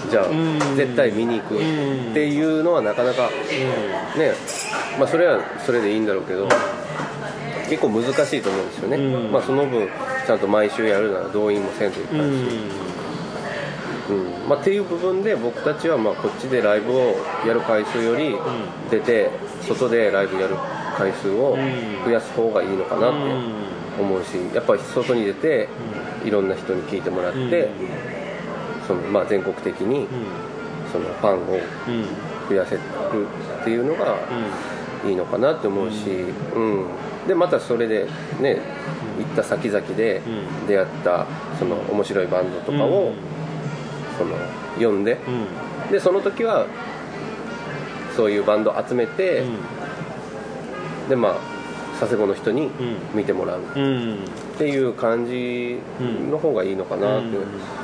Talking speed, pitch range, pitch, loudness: 270 characters per minute, 105-150 Hz, 125 Hz, -22 LUFS